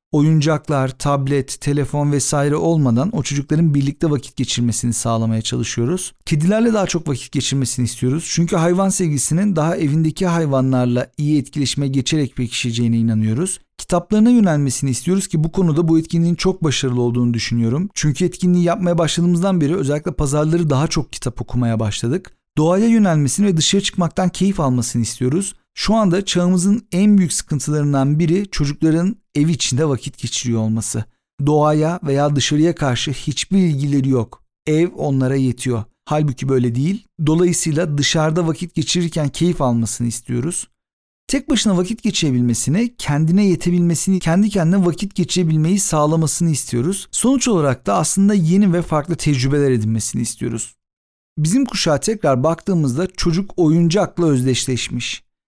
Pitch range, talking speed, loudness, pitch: 130-180 Hz, 135 wpm, -17 LUFS, 155 Hz